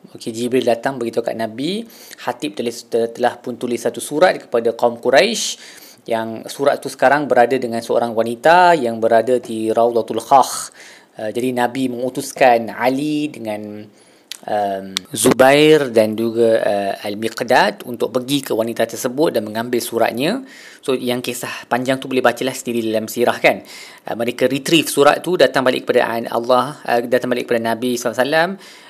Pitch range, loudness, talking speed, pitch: 115-130 Hz, -17 LUFS, 165 wpm, 120 Hz